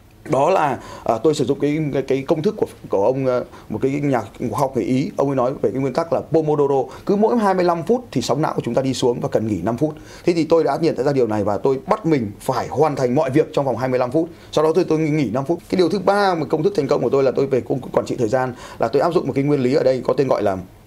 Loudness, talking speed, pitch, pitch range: -19 LUFS, 310 wpm, 140 Hz, 125-160 Hz